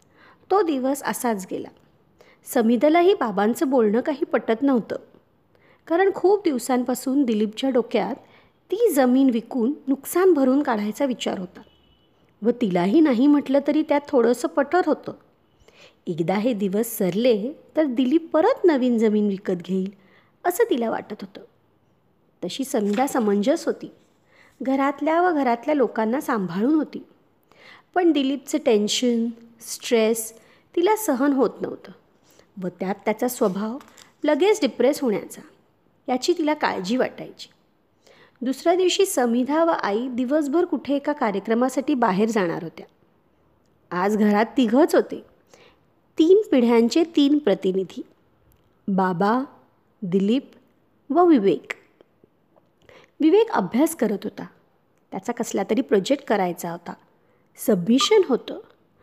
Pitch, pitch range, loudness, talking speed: 255 Hz, 220-300 Hz, -22 LUFS, 115 wpm